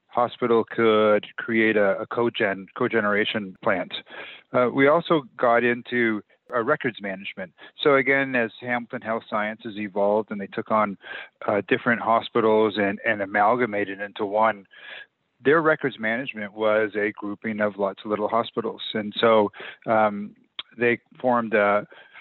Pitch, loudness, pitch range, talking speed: 110 Hz, -23 LUFS, 105-120 Hz, 140 wpm